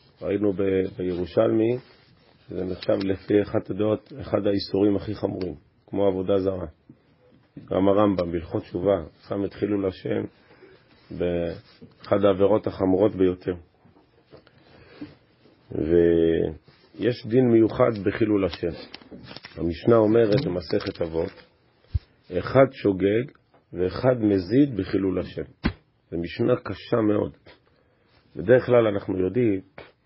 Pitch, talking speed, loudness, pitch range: 100 Hz, 100 wpm, -24 LUFS, 95-110 Hz